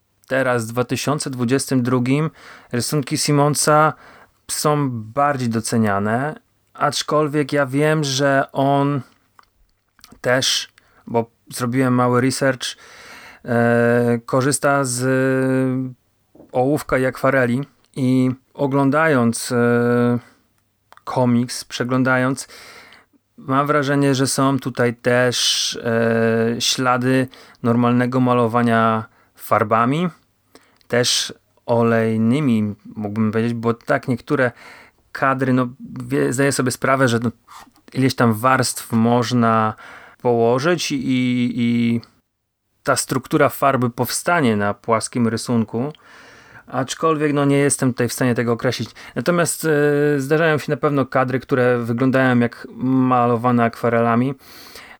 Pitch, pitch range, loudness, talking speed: 125 Hz, 120-140 Hz, -19 LUFS, 95 wpm